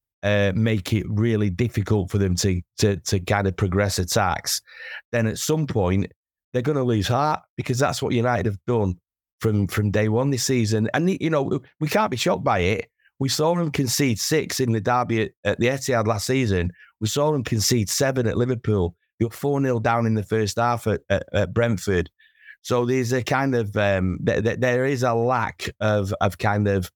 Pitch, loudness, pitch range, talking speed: 115 Hz, -23 LUFS, 105-130 Hz, 205 wpm